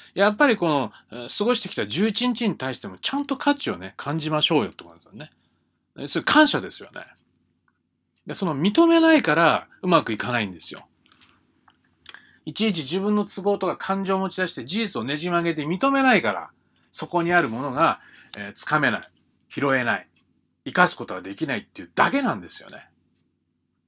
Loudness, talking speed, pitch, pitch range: -23 LUFS, 350 characters per minute, 185 Hz, 150-220 Hz